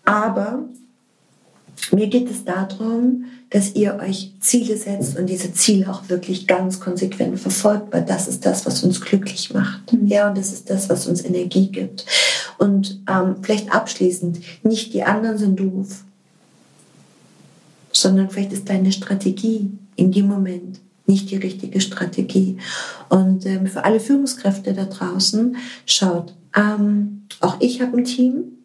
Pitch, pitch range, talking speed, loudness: 195 Hz, 190-215 Hz, 145 wpm, -19 LUFS